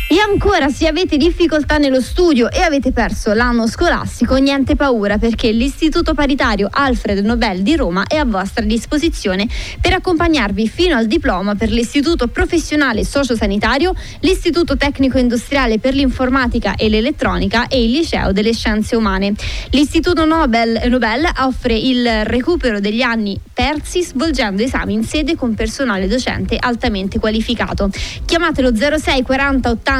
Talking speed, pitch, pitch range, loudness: 140 wpm, 255 Hz, 225-300 Hz, -15 LUFS